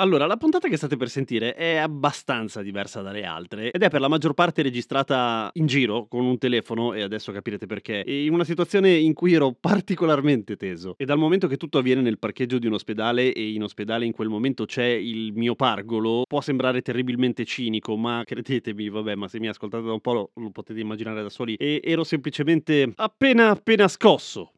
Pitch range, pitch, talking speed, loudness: 110-155 Hz, 125 Hz, 205 wpm, -23 LUFS